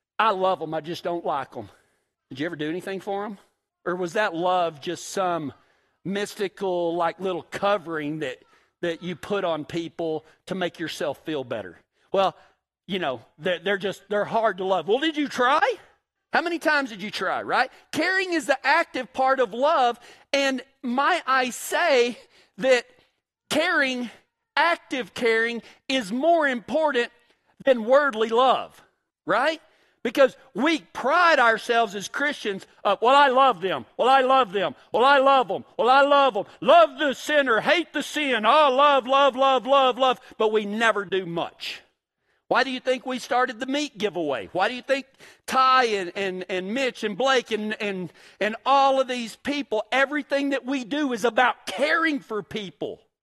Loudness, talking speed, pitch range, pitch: -23 LUFS, 175 wpm, 195-275 Hz, 245 Hz